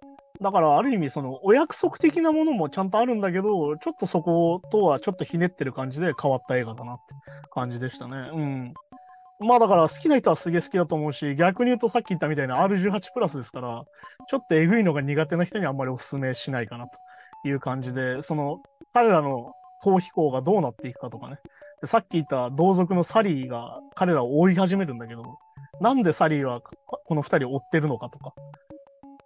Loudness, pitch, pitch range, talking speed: -24 LUFS, 165 Hz, 135-210 Hz, 425 characters per minute